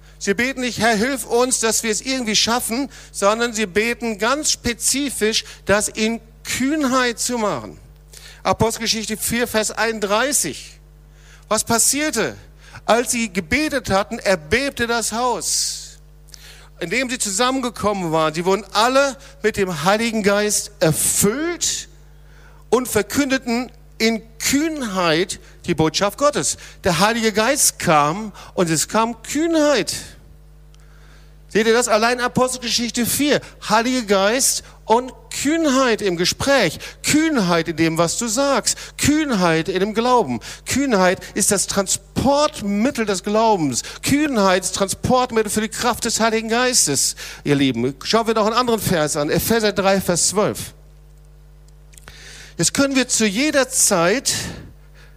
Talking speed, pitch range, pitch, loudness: 130 wpm, 180-245 Hz, 220 Hz, -18 LUFS